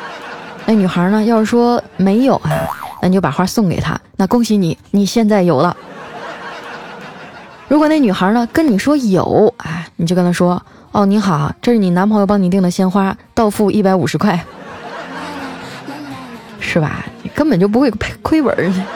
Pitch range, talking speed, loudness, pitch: 180-230 Hz, 240 characters per minute, -14 LUFS, 200 Hz